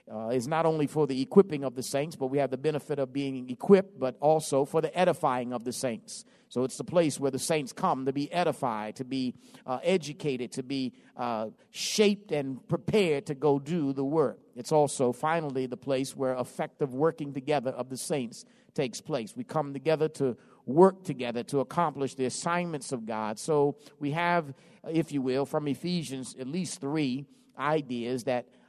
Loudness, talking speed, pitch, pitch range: -29 LUFS, 190 wpm, 140 Hz, 130-160 Hz